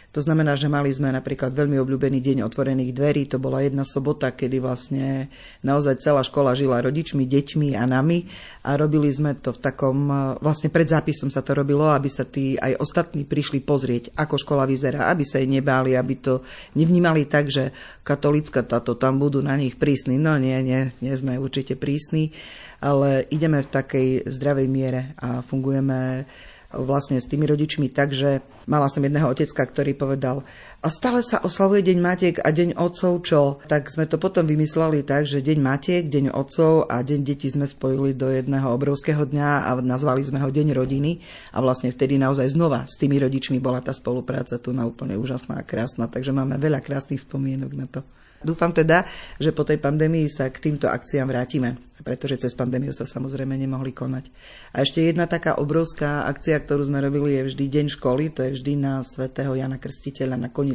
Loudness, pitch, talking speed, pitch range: -22 LUFS, 140 Hz, 185 wpm, 130-150 Hz